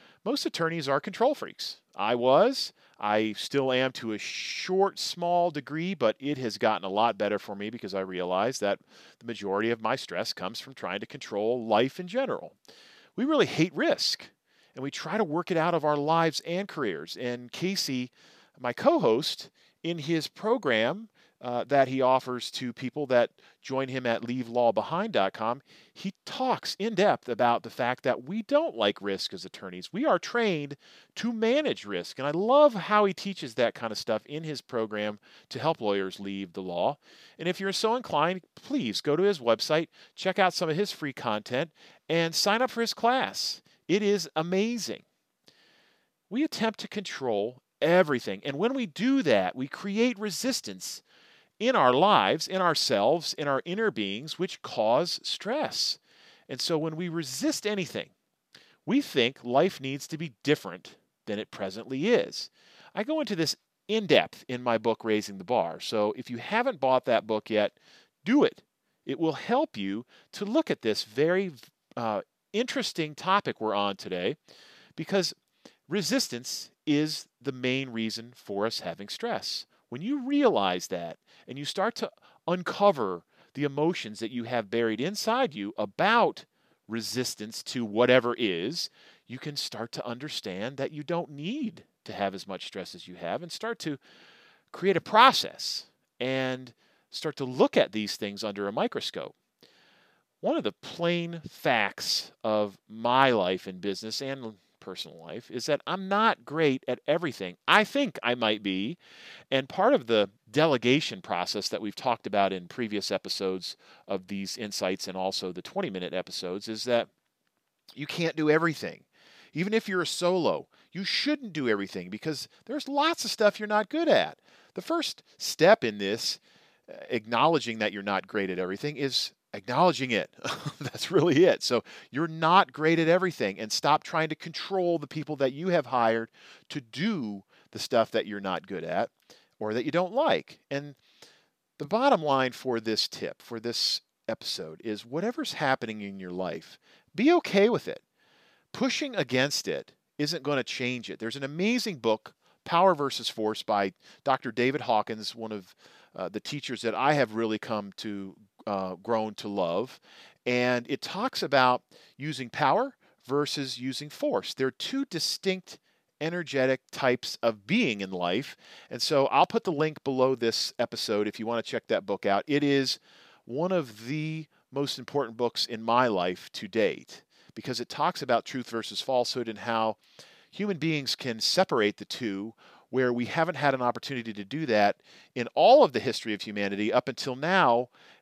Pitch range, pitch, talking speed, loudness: 115-180 Hz, 140 Hz, 170 wpm, -28 LUFS